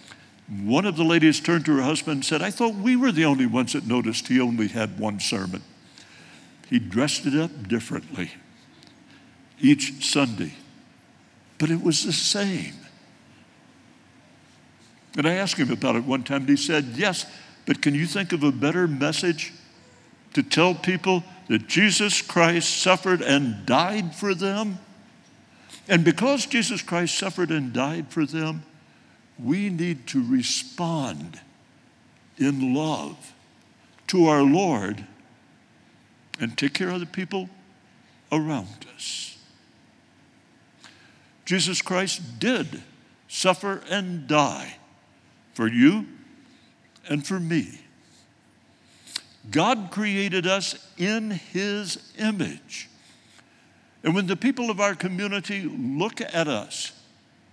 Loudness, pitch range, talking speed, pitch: -24 LUFS, 150-200 Hz, 125 wpm, 175 Hz